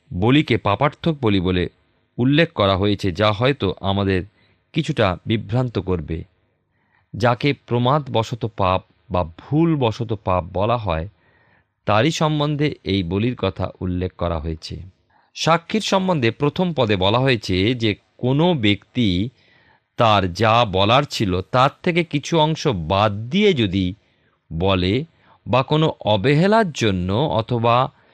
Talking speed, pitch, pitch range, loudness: 120 wpm, 110 Hz, 95-140 Hz, -20 LUFS